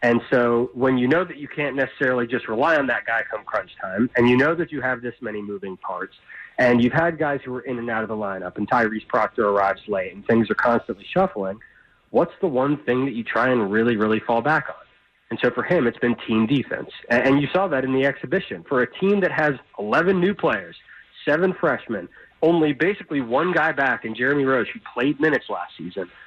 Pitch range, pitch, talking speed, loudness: 115-155 Hz, 130 Hz, 230 wpm, -22 LUFS